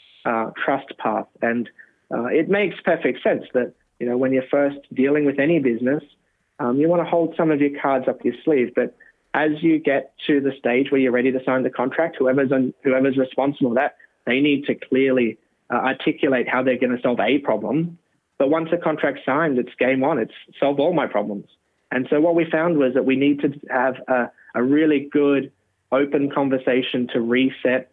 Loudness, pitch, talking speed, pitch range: -21 LUFS, 135 Hz, 205 wpm, 130-150 Hz